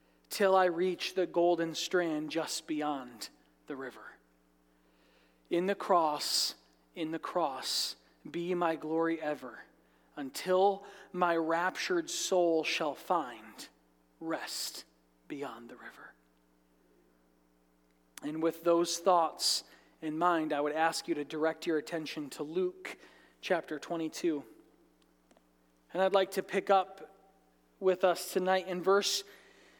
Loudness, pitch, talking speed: -32 LUFS, 160 Hz, 120 wpm